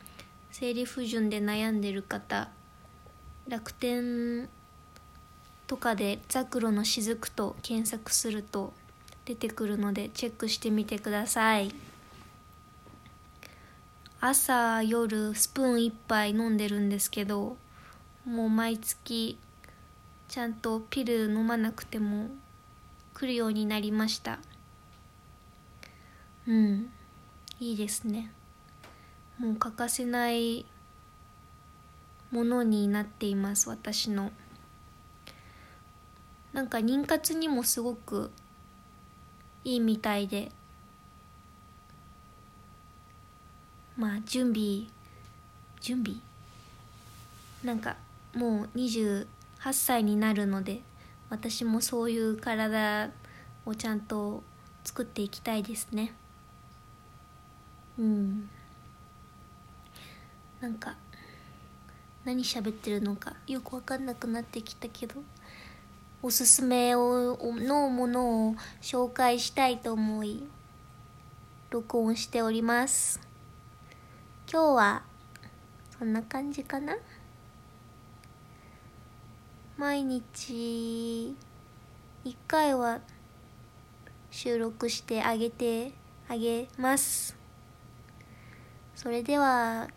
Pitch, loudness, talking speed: 220 Hz, -30 LUFS, 165 characters per minute